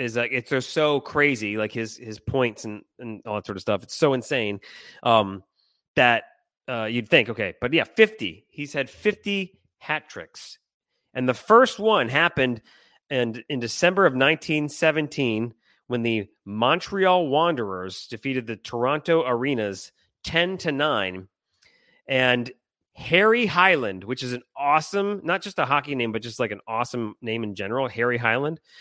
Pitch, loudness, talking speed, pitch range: 125 Hz, -23 LUFS, 160 wpm, 115-160 Hz